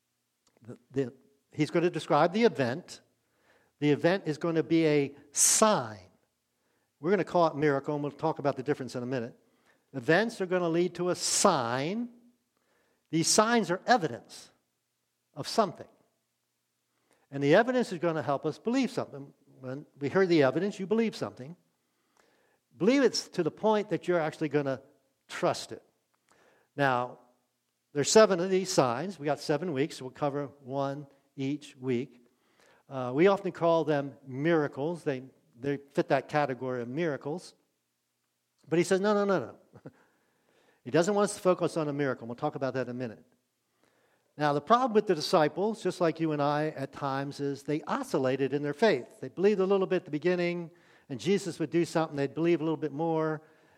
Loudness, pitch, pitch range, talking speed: -29 LUFS, 150 Hz, 135-175 Hz, 185 wpm